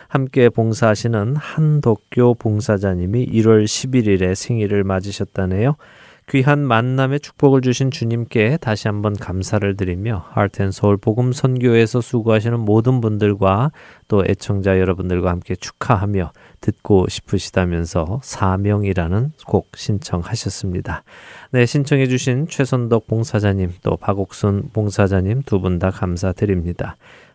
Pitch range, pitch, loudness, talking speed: 95-125 Hz, 105 Hz, -18 LUFS, 300 characters per minute